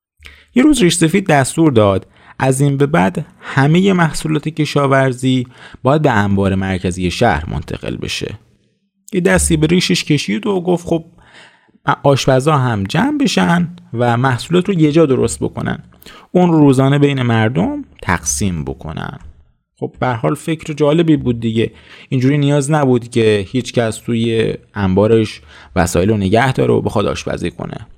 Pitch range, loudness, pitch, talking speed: 110-165 Hz, -15 LUFS, 135 Hz, 145 wpm